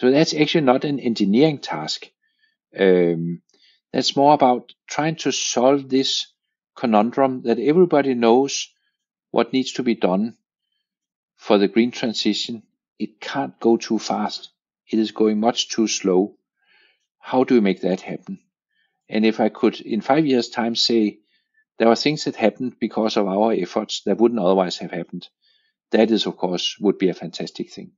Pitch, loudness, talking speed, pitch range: 120 Hz, -20 LUFS, 165 wpm, 110-145 Hz